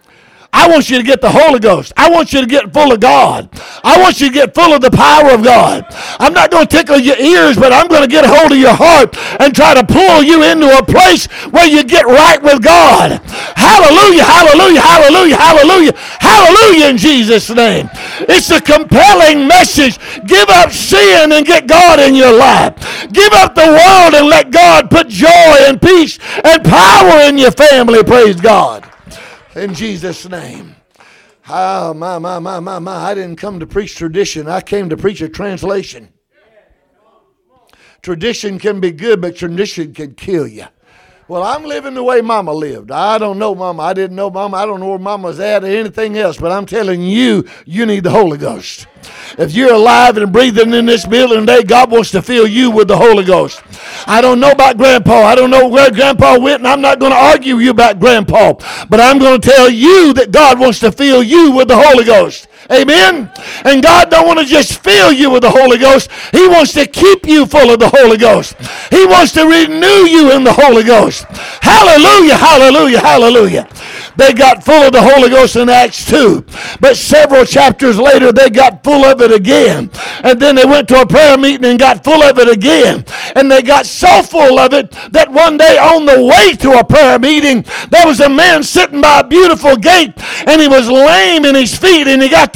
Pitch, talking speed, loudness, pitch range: 265 Hz, 210 wpm, -5 LUFS, 230-310 Hz